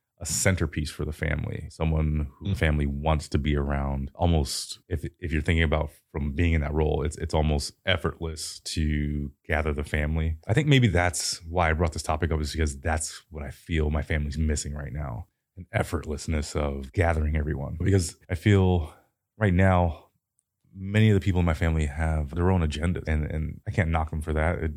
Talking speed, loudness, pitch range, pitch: 200 wpm, -27 LUFS, 75-90 Hz, 80 Hz